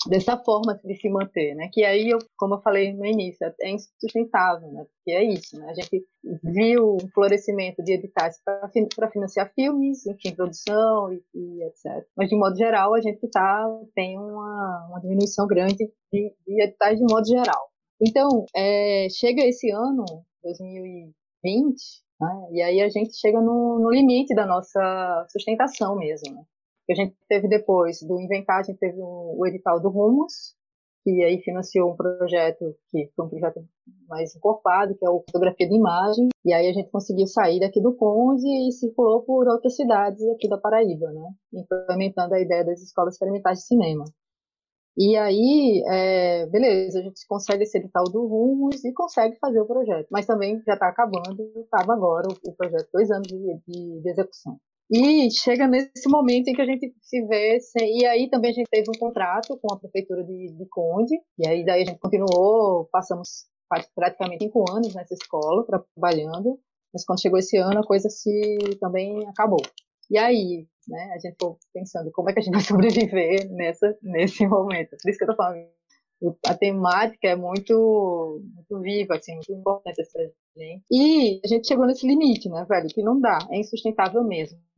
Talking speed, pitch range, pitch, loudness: 185 wpm, 180-225 Hz, 200 Hz, -22 LUFS